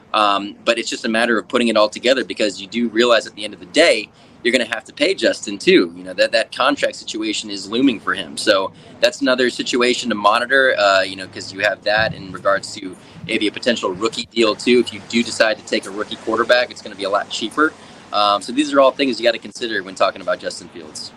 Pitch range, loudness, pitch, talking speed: 105-135 Hz, -18 LUFS, 120 Hz, 260 wpm